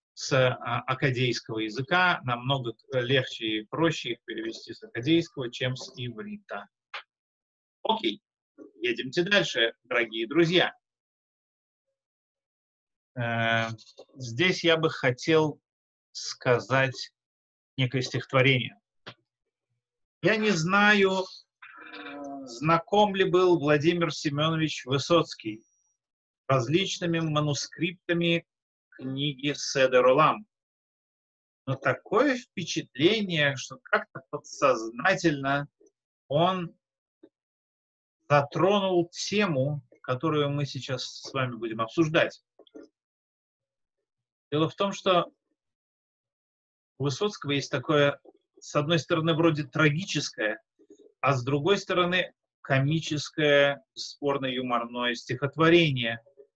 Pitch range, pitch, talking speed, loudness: 130-175 Hz, 145 Hz, 80 wpm, -26 LUFS